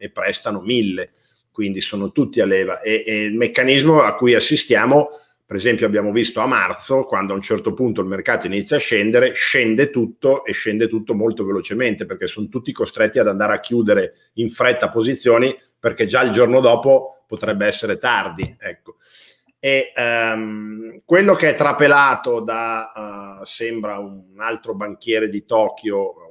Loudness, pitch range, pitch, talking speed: -17 LUFS, 105-135 Hz, 115 Hz, 165 wpm